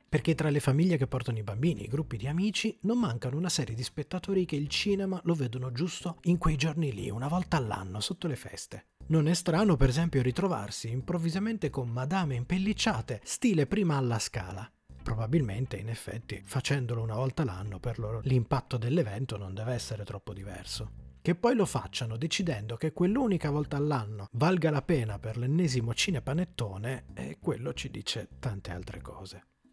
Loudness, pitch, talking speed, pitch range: -31 LUFS, 135 Hz, 175 wpm, 115-170 Hz